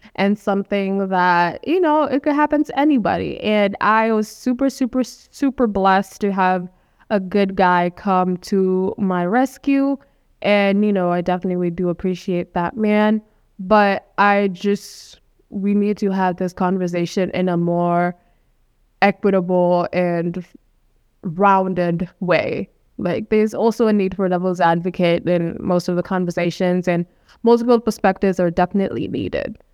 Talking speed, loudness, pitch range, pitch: 145 wpm, -19 LUFS, 180-215 Hz, 195 Hz